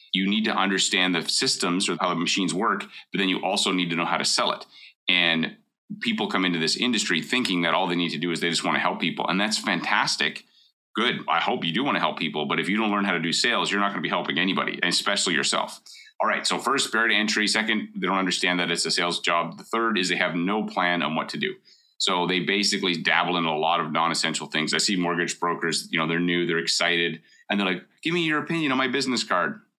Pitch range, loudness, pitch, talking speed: 85-105 Hz, -23 LUFS, 90 Hz, 260 wpm